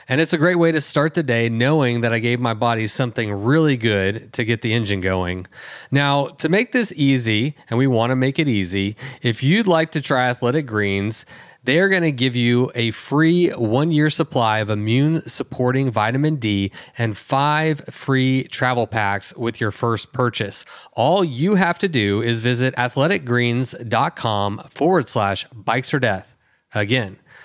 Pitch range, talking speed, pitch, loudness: 115-150 Hz, 175 wpm, 125 Hz, -19 LUFS